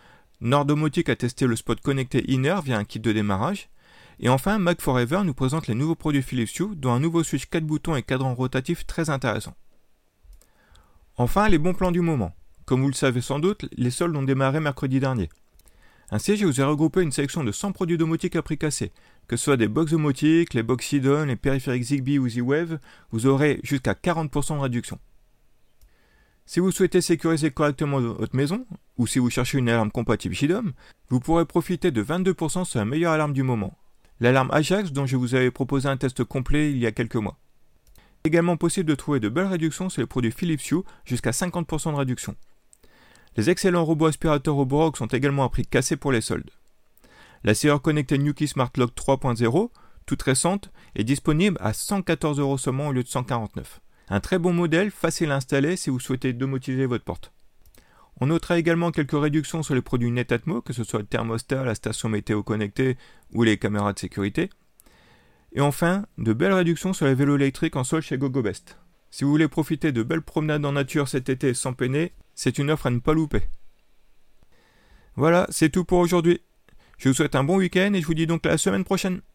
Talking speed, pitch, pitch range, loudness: 200 wpm, 140 Hz, 125-165 Hz, -24 LUFS